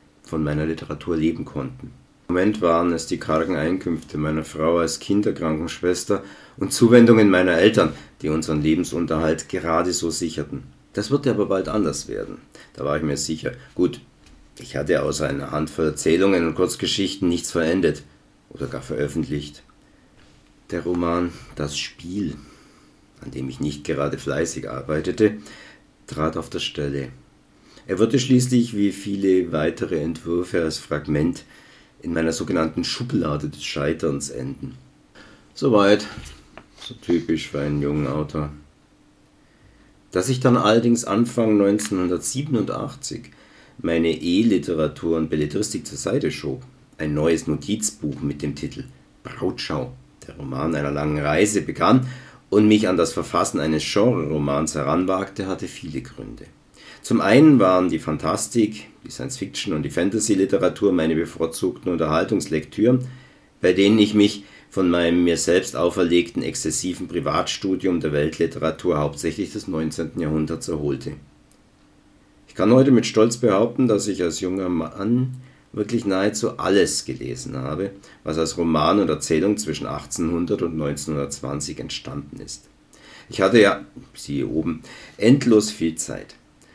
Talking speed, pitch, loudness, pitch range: 135 wpm, 85 Hz, -21 LUFS, 75-105 Hz